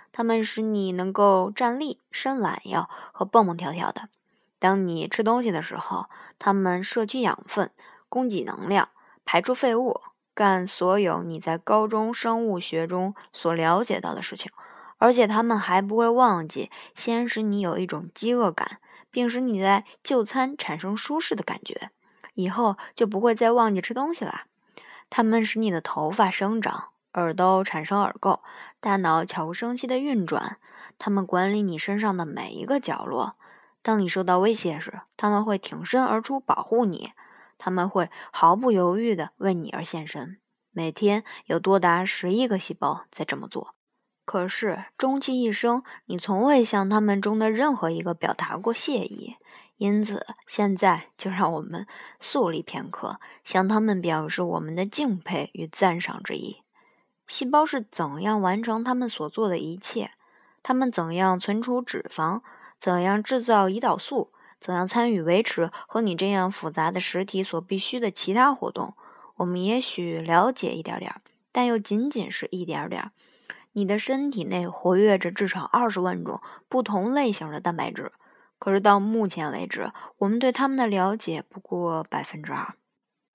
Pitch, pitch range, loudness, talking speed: 205 Hz, 180-235 Hz, -25 LUFS, 245 characters per minute